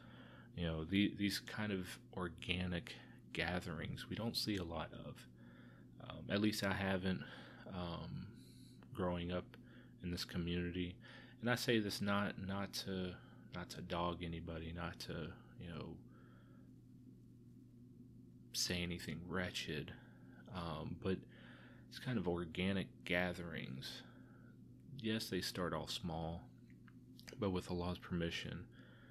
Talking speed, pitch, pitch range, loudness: 125 wpm, 90 Hz, 85-100 Hz, -43 LUFS